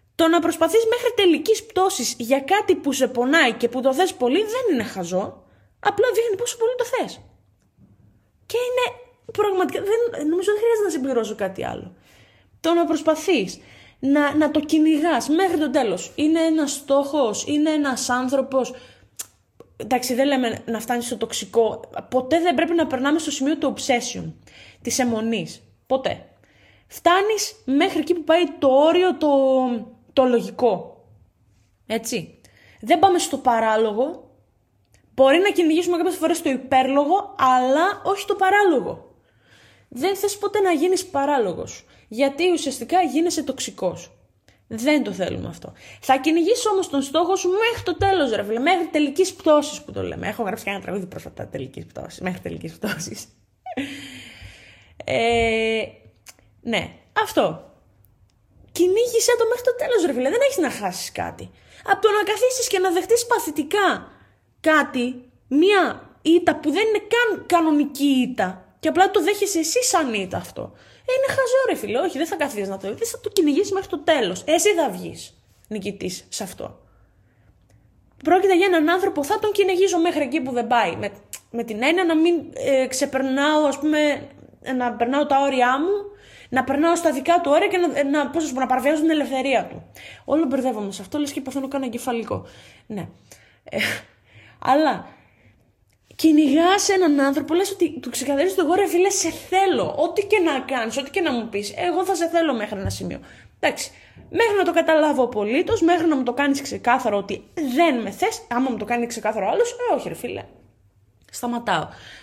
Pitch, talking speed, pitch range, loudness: 305 Hz, 165 wpm, 250-370 Hz, -21 LUFS